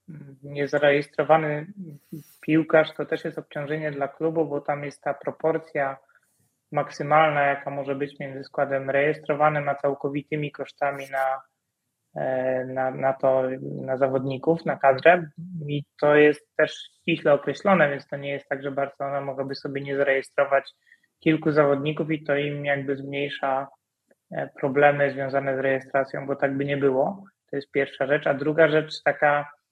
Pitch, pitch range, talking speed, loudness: 145 Hz, 140-155 Hz, 145 wpm, -24 LUFS